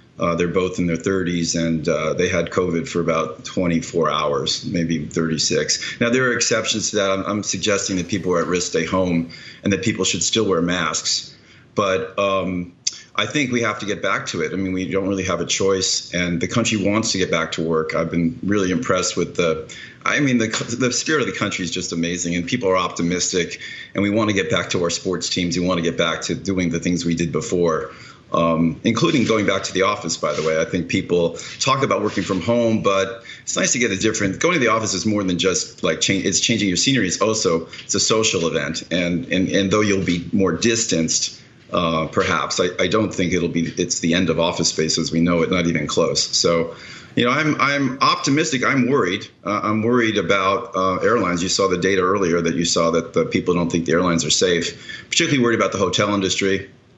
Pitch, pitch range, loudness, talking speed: 95 Hz, 85-105 Hz, -19 LUFS, 235 wpm